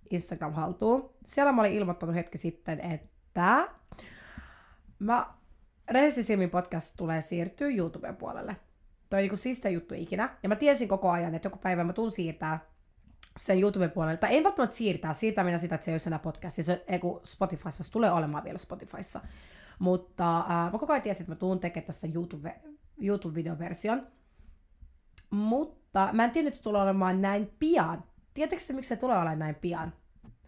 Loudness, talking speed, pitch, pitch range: -30 LUFS, 170 wpm, 180 Hz, 165-220 Hz